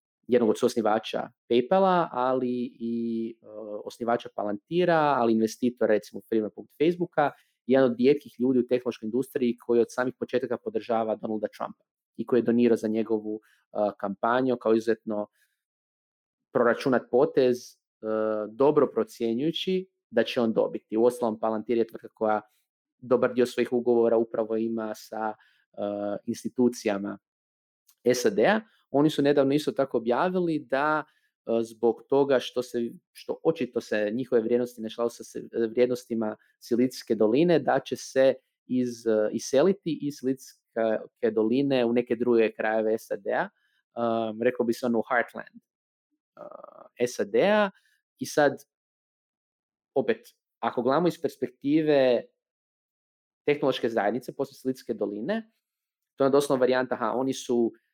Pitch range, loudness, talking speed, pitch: 110-135 Hz, -27 LUFS, 130 wpm, 120 Hz